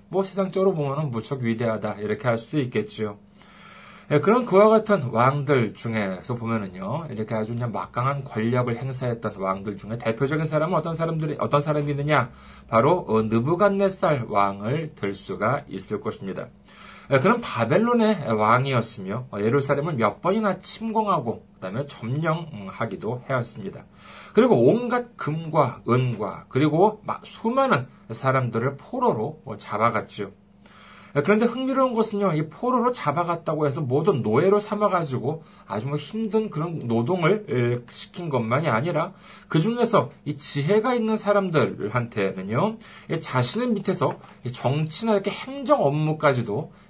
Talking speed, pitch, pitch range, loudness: 315 characters per minute, 145 Hz, 120-195 Hz, -24 LUFS